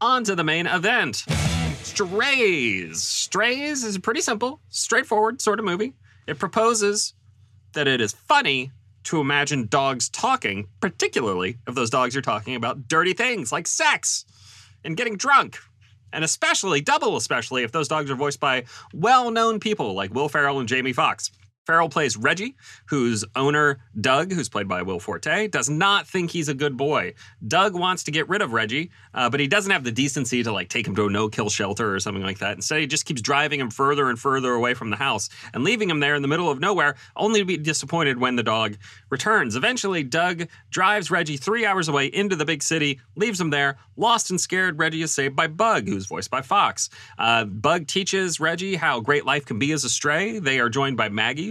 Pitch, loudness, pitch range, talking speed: 145 Hz, -22 LUFS, 120-185 Hz, 205 wpm